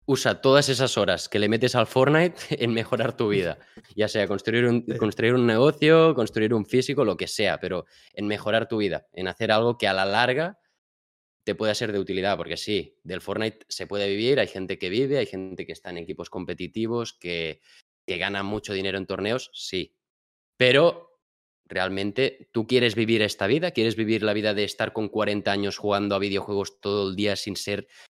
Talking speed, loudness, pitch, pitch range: 200 wpm, -24 LUFS, 110 Hz, 100-120 Hz